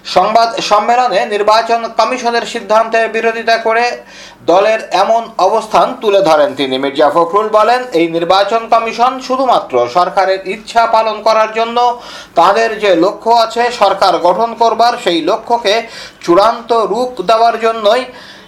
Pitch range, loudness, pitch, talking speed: 195-230 Hz, -11 LUFS, 225 Hz, 125 wpm